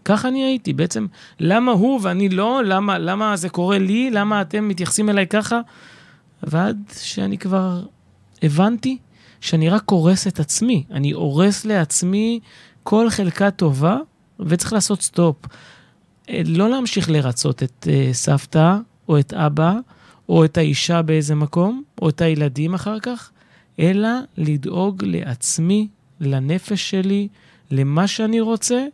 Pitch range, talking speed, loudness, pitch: 155-210 Hz, 130 wpm, -19 LUFS, 185 Hz